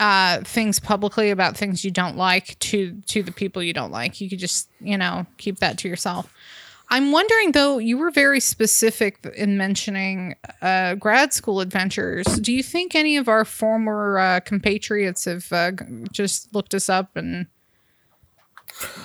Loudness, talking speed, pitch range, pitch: -21 LUFS, 165 wpm, 185-220 Hz, 200 Hz